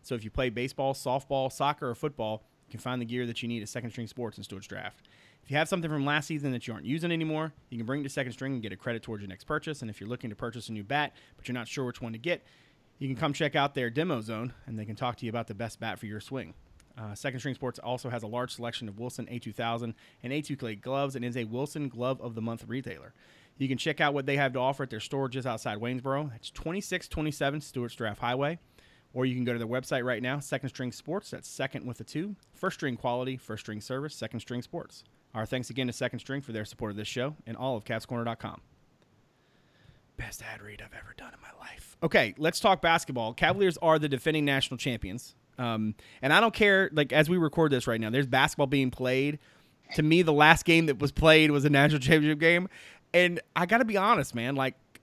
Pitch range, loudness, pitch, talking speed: 120-150 Hz, -29 LUFS, 130 Hz, 255 wpm